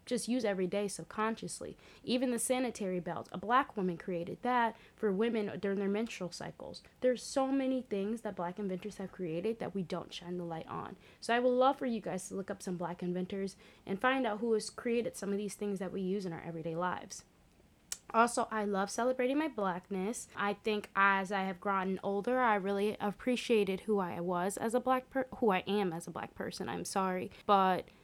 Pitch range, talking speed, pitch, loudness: 185-230 Hz, 210 wpm, 200 Hz, -35 LUFS